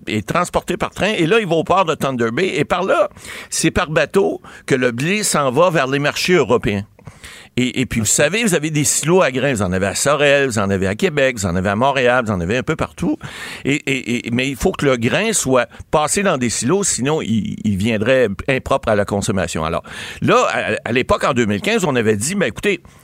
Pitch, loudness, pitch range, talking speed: 135 Hz, -17 LUFS, 110-165 Hz, 245 wpm